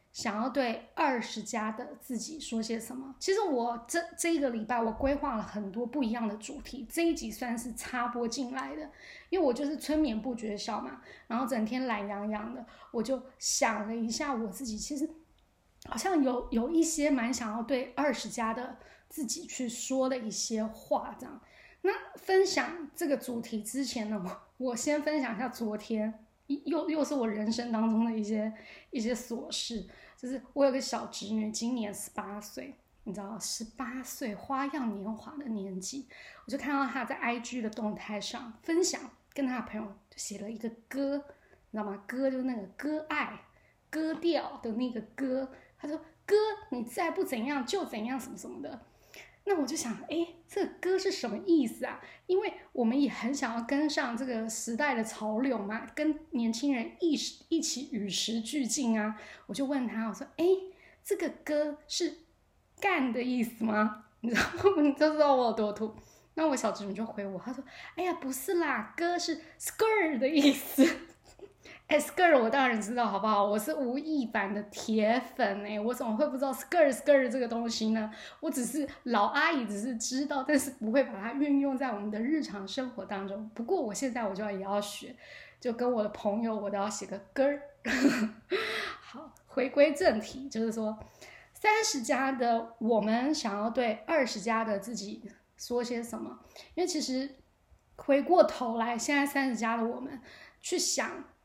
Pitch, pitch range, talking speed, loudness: 255 Hz, 225-290 Hz, 265 characters per minute, -32 LUFS